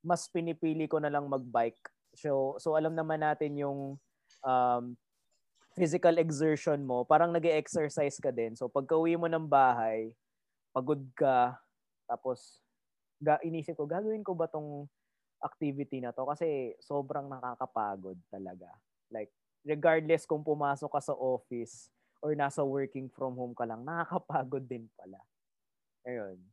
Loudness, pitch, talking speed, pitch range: -32 LUFS, 145 Hz, 140 wpm, 125-160 Hz